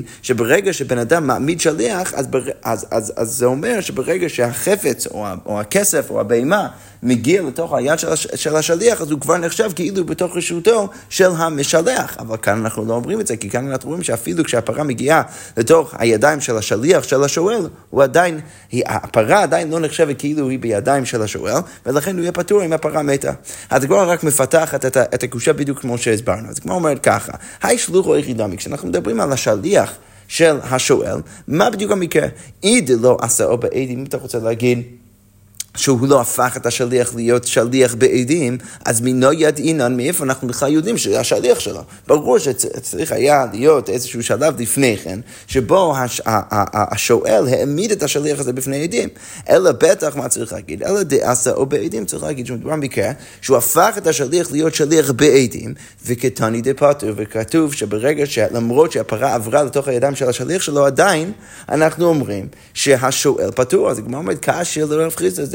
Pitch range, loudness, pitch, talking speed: 120-160 Hz, -16 LUFS, 135 Hz, 170 wpm